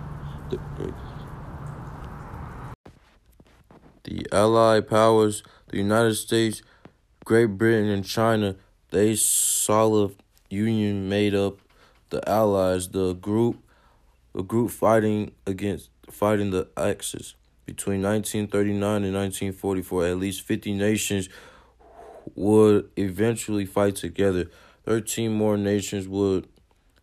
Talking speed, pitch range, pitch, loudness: 95 wpm, 95-110 Hz, 100 Hz, -23 LUFS